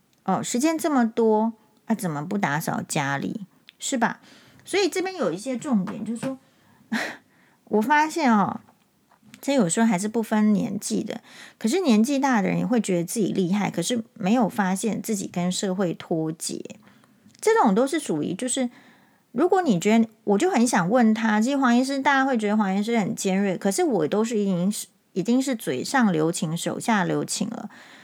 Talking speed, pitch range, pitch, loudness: 270 characters per minute, 195-245 Hz, 220 Hz, -23 LUFS